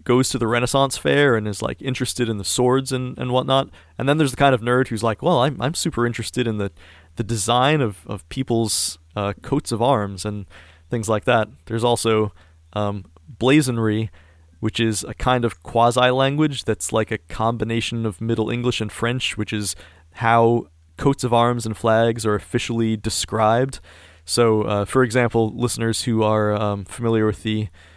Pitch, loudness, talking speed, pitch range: 115 Hz, -21 LUFS, 185 wpm, 105-125 Hz